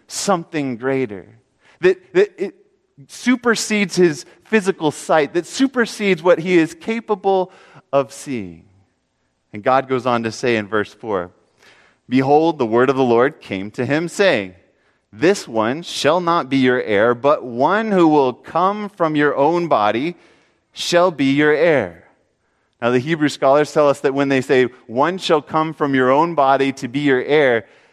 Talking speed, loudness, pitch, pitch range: 165 wpm, -17 LUFS, 145 Hz, 130-185 Hz